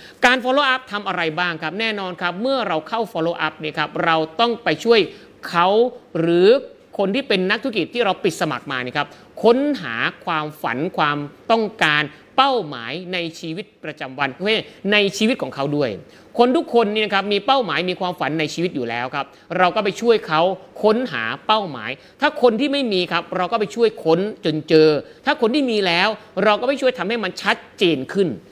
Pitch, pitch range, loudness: 190 Hz, 160-235 Hz, -19 LUFS